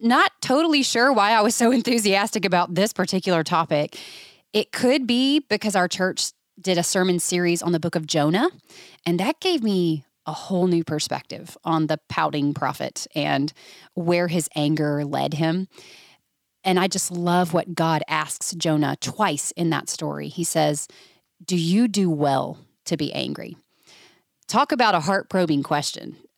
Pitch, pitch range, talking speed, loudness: 180 Hz, 160-210 Hz, 165 wpm, -22 LUFS